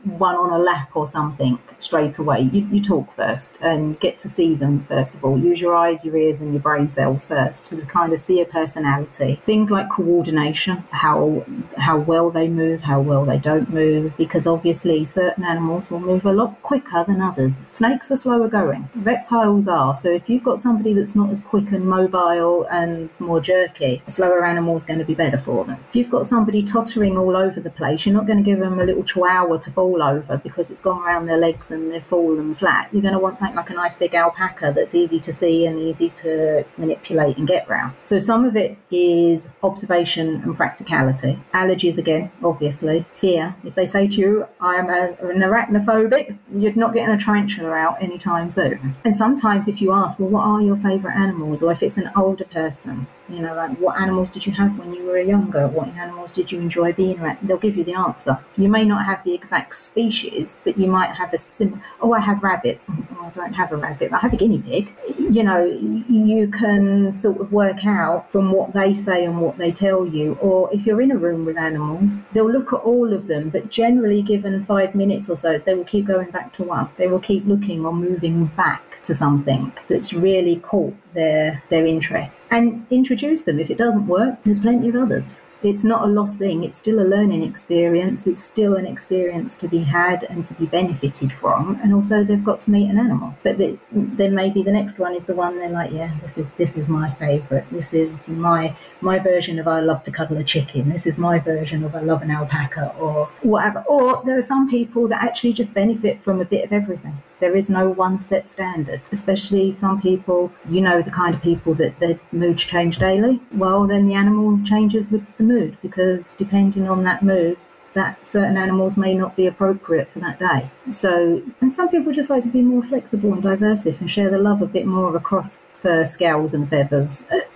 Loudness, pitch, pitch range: -18 LUFS, 185 Hz, 165-205 Hz